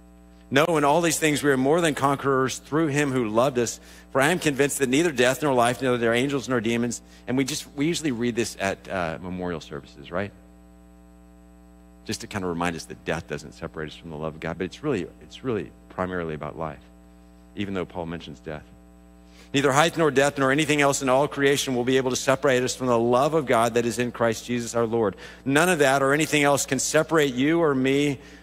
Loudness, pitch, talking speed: -23 LUFS, 120 Hz, 230 wpm